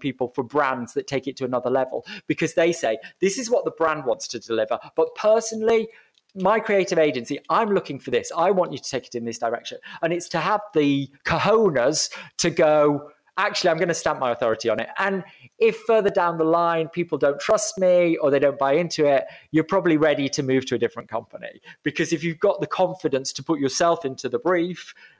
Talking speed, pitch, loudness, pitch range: 220 wpm, 160 Hz, -22 LUFS, 135-185 Hz